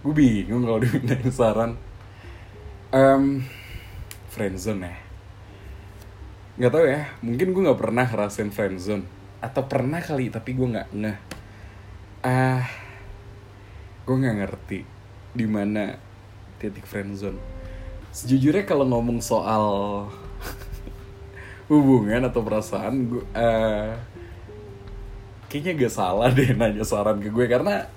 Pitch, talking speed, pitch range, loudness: 105 Hz, 115 wpm, 100-125 Hz, -23 LUFS